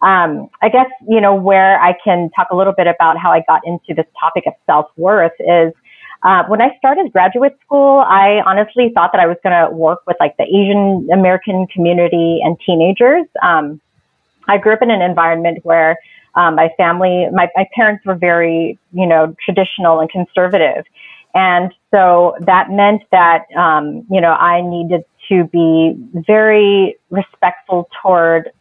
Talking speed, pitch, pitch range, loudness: 170 wpm, 180 Hz, 170-200 Hz, -12 LUFS